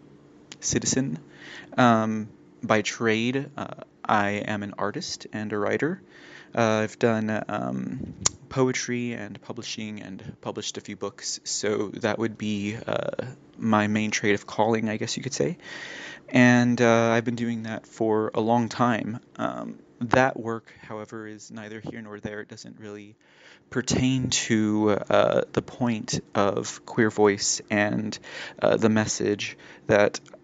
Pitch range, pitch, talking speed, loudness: 105-120 Hz, 110 Hz, 150 wpm, -25 LUFS